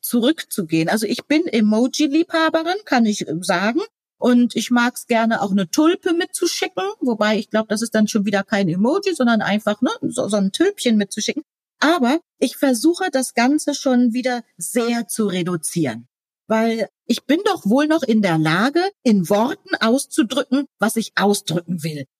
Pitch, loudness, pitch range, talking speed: 235 Hz, -19 LUFS, 210-295 Hz, 165 wpm